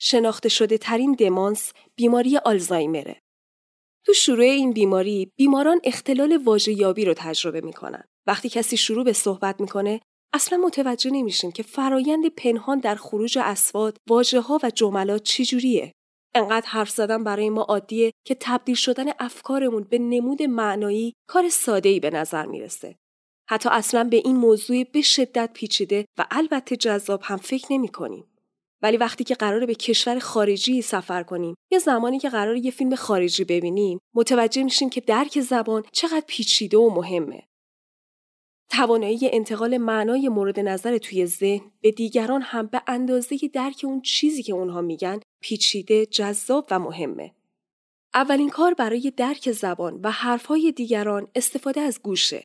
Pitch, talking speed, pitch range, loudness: 230 Hz, 150 wpm, 205-260 Hz, -21 LUFS